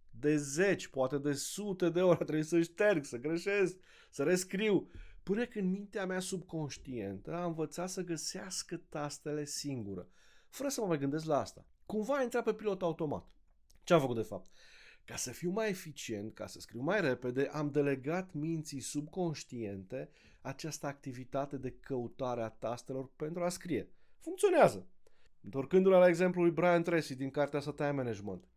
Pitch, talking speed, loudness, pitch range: 155 Hz, 165 wpm, -35 LUFS, 135-180 Hz